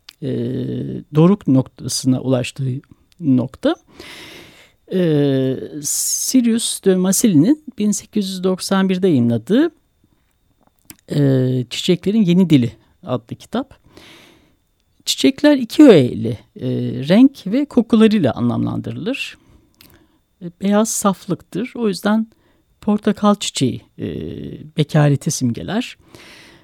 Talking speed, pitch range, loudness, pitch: 75 wpm, 130-215 Hz, -17 LUFS, 175 Hz